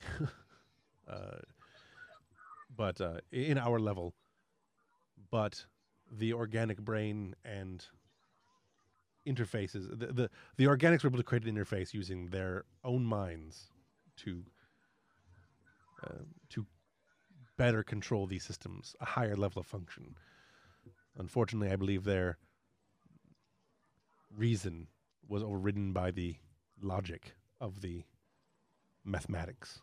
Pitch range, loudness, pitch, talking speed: 95-120 Hz, -37 LUFS, 105 Hz, 105 wpm